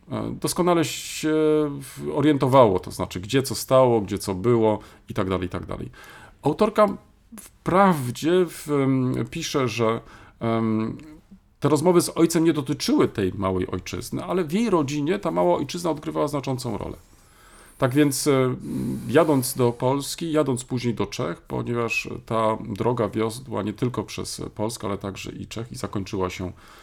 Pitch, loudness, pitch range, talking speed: 125 Hz, -23 LUFS, 105-150 Hz, 145 wpm